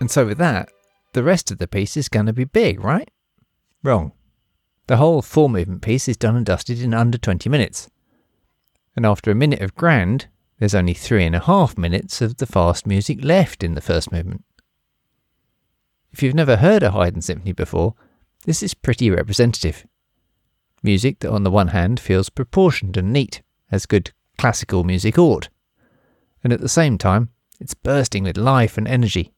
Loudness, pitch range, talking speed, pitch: -18 LUFS, 95-135 Hz, 180 wpm, 110 Hz